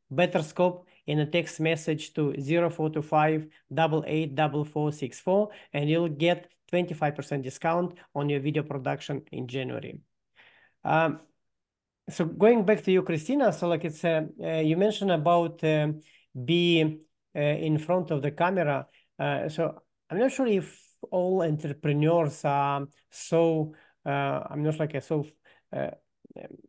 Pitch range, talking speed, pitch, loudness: 150-175 Hz, 155 wpm, 160 Hz, -27 LUFS